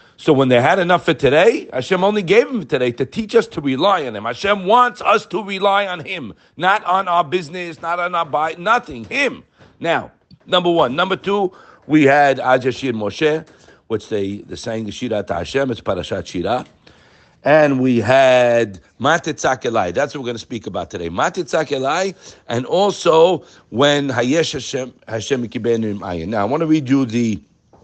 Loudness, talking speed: -17 LUFS, 175 wpm